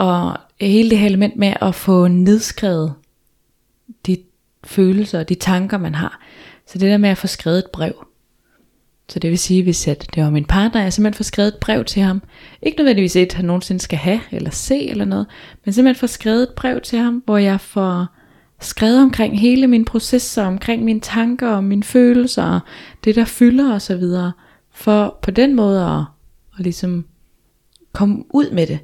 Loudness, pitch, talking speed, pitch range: -16 LUFS, 200 Hz, 190 wpm, 180-225 Hz